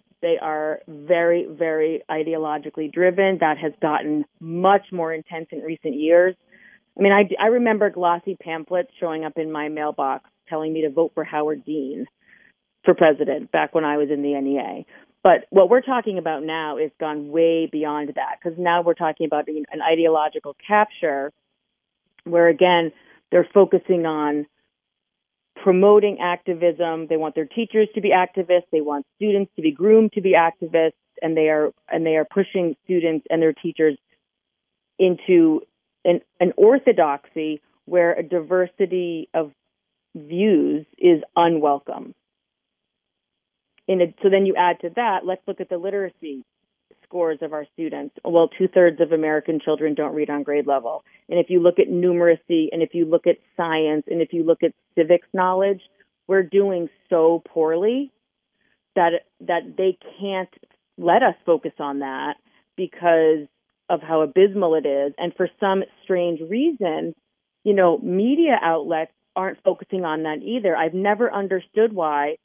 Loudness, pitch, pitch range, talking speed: -20 LUFS, 170 Hz, 155-190 Hz, 160 wpm